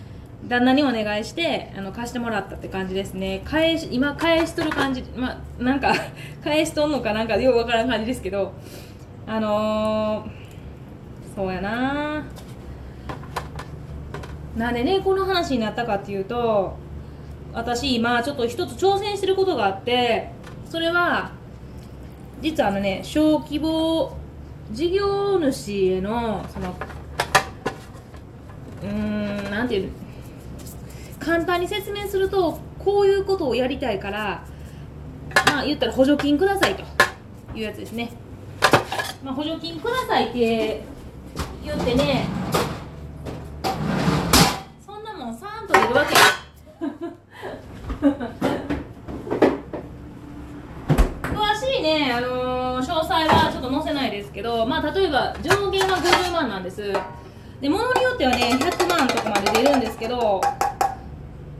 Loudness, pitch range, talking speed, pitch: -22 LUFS, 215-335 Hz, 225 characters per minute, 255 Hz